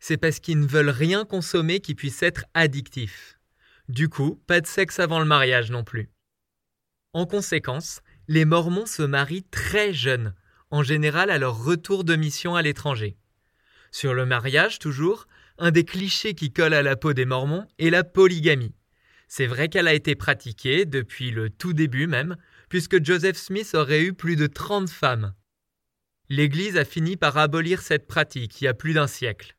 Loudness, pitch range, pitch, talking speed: -23 LUFS, 130-175 Hz, 155 Hz, 180 wpm